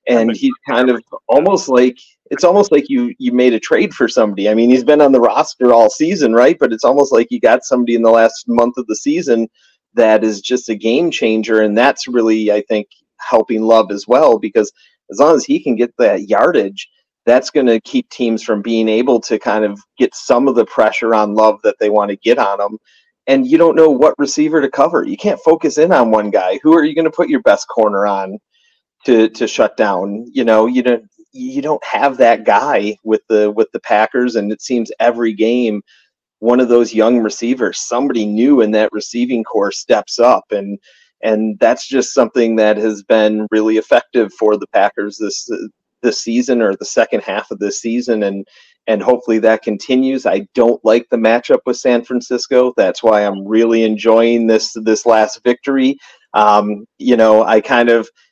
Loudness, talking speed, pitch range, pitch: -13 LUFS, 205 wpm, 110-125 Hz, 115 Hz